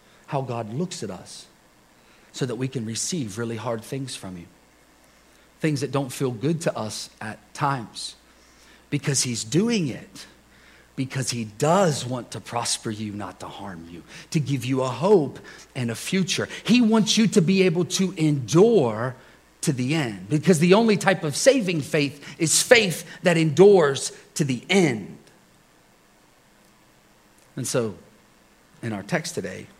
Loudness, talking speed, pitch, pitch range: -23 LUFS, 155 wpm, 145 Hz, 120-180 Hz